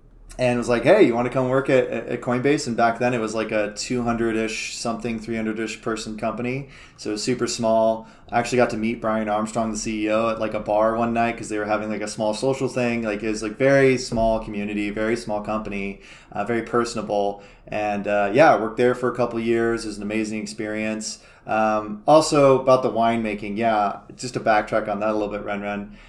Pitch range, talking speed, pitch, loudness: 105-120 Hz, 225 wpm, 110 Hz, -22 LUFS